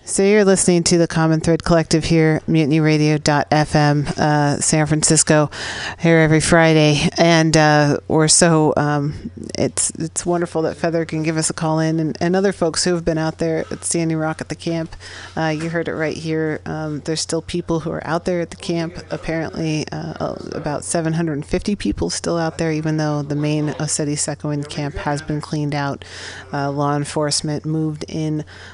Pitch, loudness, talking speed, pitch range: 155 Hz, -18 LUFS, 185 wpm, 150-165 Hz